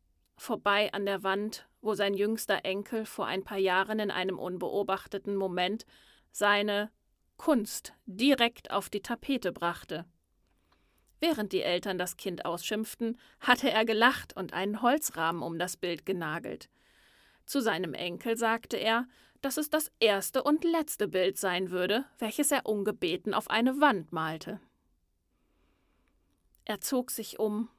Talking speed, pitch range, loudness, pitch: 140 wpm, 190-235 Hz, -30 LUFS, 205 Hz